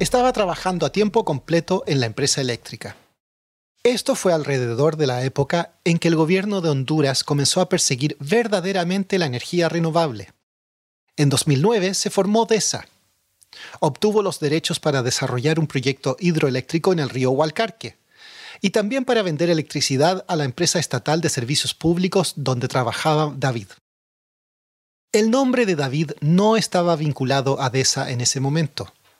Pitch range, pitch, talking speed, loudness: 135-185 Hz, 155 Hz, 150 wpm, -20 LUFS